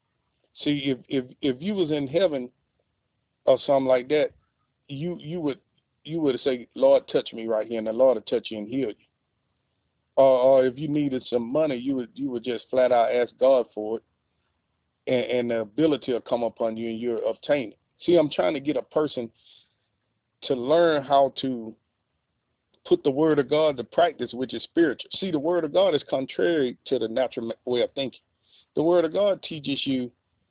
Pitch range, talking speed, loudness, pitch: 115-150 Hz, 200 wpm, -25 LUFS, 130 Hz